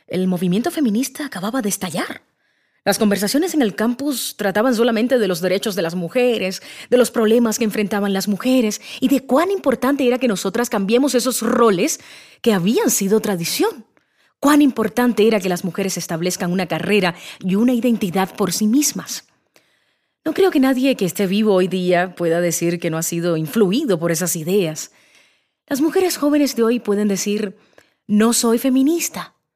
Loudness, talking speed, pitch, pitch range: -18 LUFS, 170 wpm, 220 Hz, 190-255 Hz